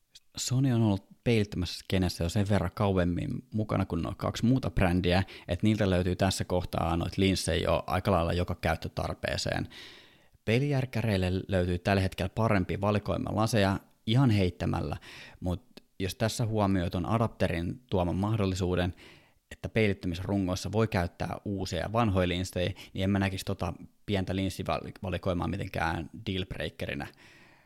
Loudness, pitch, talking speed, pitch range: -30 LUFS, 95 Hz, 130 wpm, 90-105 Hz